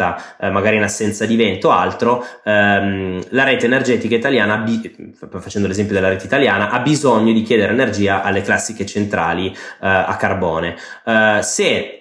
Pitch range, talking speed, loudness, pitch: 100-110 Hz, 155 wpm, -16 LUFS, 105 Hz